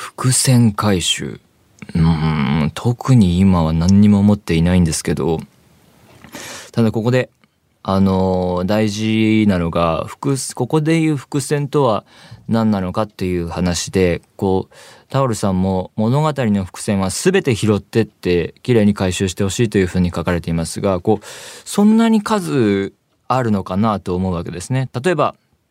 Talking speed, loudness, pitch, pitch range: 290 characters per minute, -17 LUFS, 105 Hz, 90-125 Hz